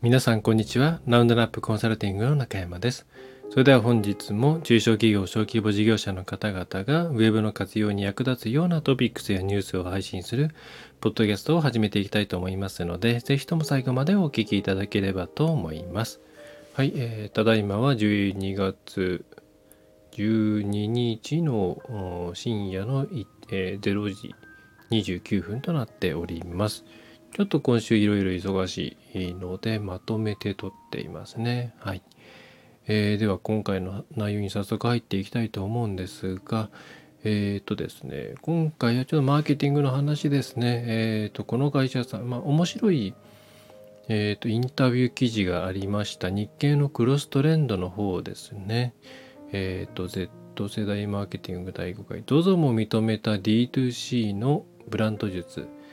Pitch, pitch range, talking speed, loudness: 110 Hz, 100-130 Hz, 330 characters per minute, -26 LUFS